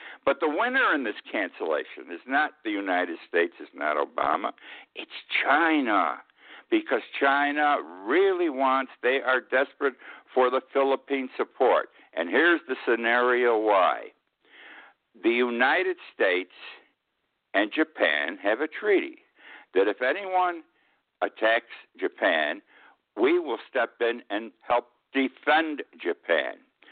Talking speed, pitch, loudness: 120 wpm, 155 Hz, -26 LUFS